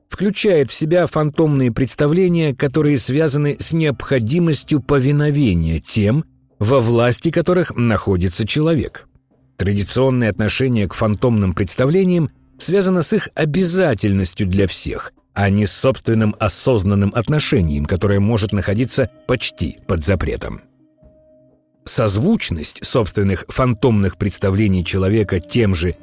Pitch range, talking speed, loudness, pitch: 100-150 Hz, 105 wpm, -16 LUFS, 120 Hz